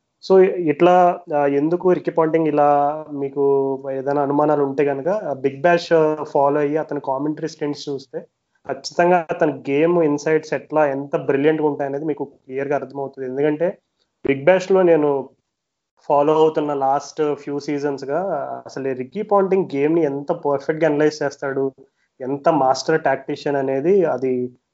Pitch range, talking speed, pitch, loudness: 140-160 Hz, 135 wpm, 145 Hz, -19 LUFS